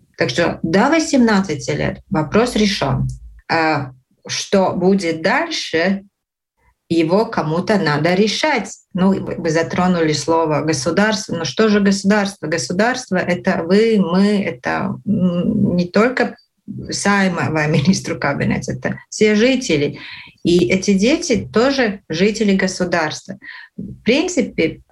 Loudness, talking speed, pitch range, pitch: -17 LUFS, 115 wpm, 165-215 Hz, 190 Hz